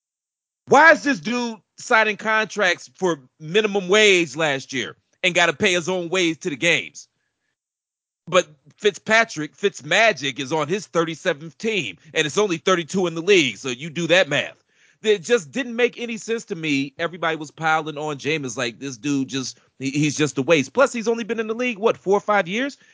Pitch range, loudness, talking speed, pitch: 150-215 Hz, -20 LUFS, 195 wpm, 175 Hz